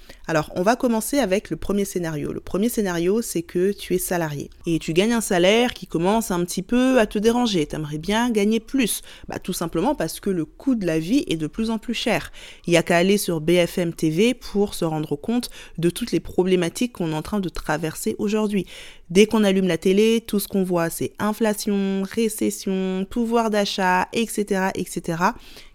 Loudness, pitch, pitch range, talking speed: -22 LUFS, 195 Hz, 170-220 Hz, 205 wpm